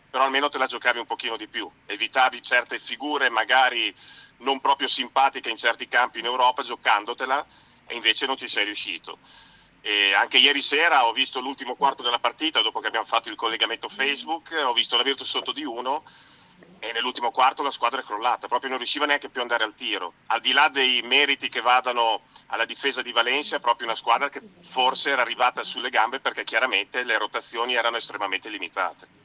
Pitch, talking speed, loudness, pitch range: 130 Hz, 195 wpm, -22 LUFS, 120-140 Hz